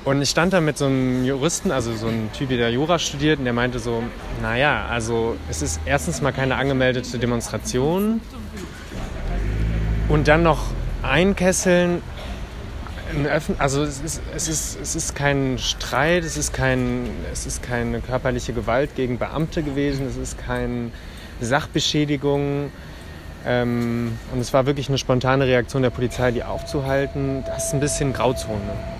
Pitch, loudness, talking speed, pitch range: 130 Hz, -22 LUFS, 150 wpm, 120-145 Hz